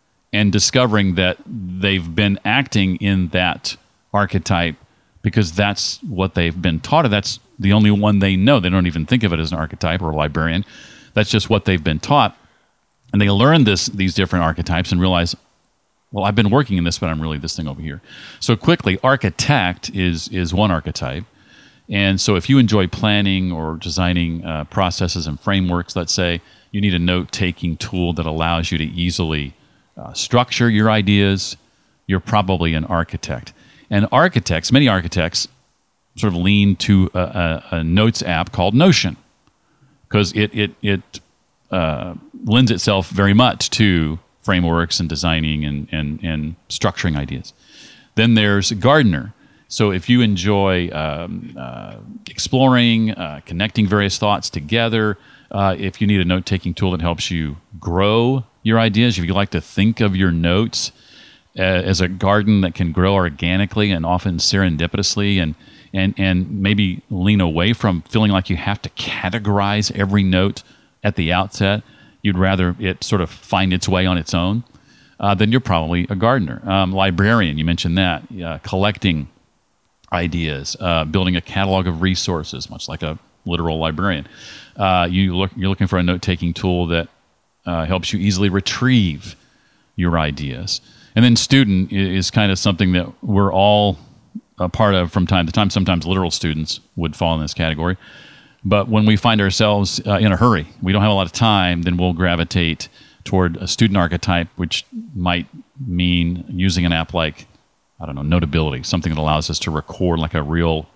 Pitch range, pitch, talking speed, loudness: 85-105 Hz, 95 Hz, 175 wpm, -18 LUFS